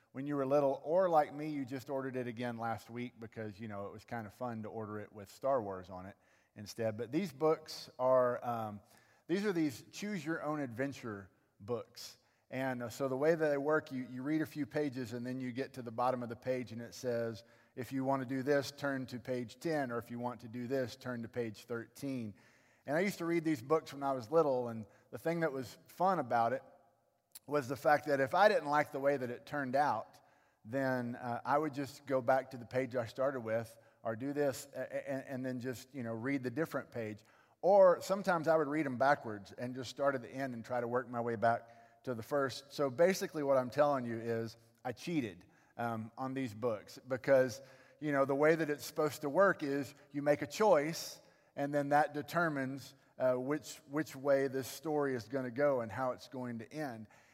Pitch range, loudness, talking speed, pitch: 120-145 Hz, -36 LUFS, 230 wpm, 130 Hz